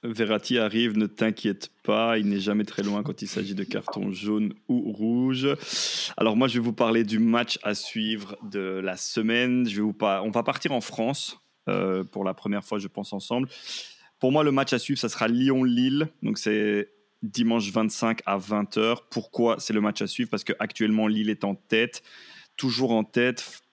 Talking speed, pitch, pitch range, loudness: 200 wpm, 110 Hz, 105-125 Hz, -26 LUFS